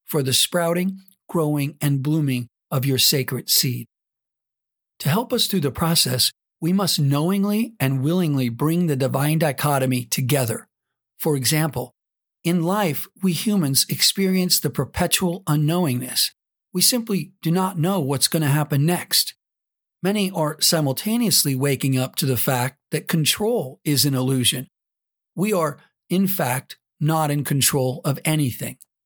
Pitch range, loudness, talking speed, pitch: 135-180 Hz, -21 LUFS, 140 wpm, 150 Hz